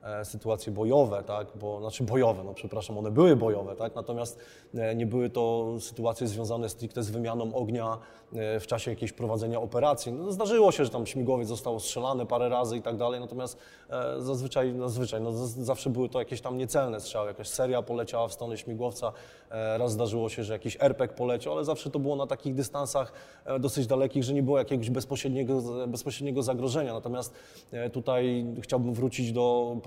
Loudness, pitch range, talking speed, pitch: -30 LUFS, 115-130 Hz, 170 wpm, 120 Hz